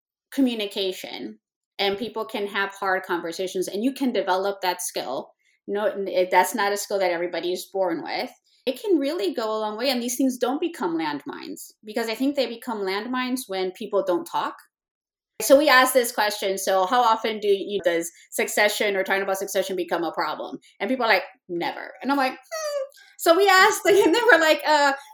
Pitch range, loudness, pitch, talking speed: 190-275 Hz, -23 LUFS, 220 Hz, 205 wpm